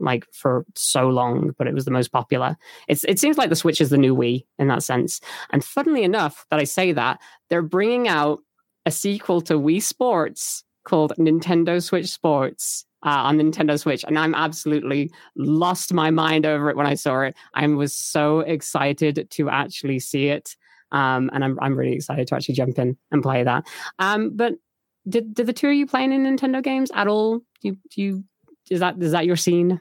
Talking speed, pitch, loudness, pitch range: 205 wpm, 160 Hz, -21 LUFS, 140-185 Hz